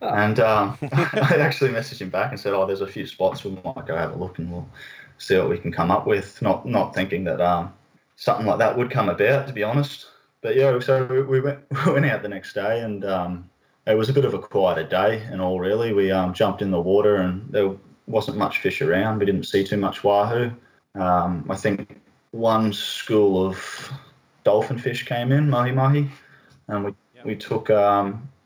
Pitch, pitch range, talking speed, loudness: 115 Hz, 100-135 Hz, 215 wpm, -22 LUFS